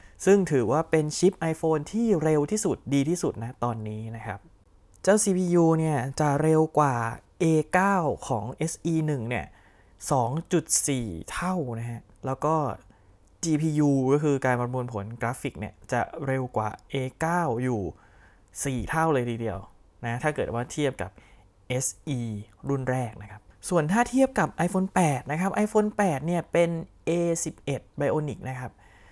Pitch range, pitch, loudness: 110-160 Hz, 135 Hz, -26 LUFS